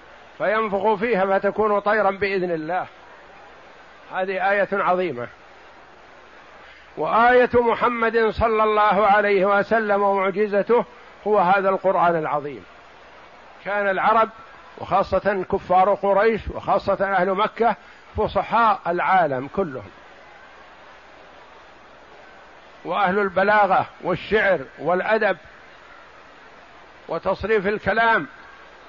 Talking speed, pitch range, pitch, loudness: 80 wpm, 190-215 Hz, 200 Hz, -20 LUFS